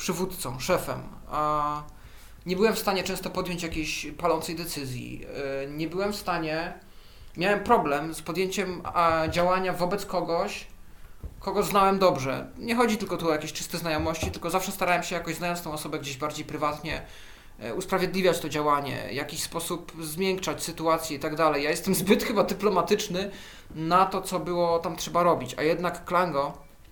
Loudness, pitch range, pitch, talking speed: -27 LUFS, 150-185 Hz, 170 Hz, 160 wpm